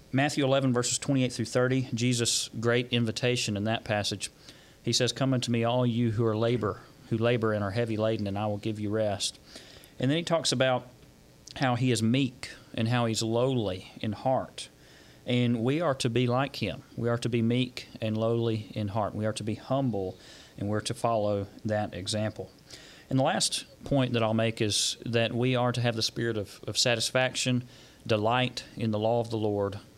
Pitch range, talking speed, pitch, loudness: 110-125 Hz, 200 wpm, 115 Hz, -28 LUFS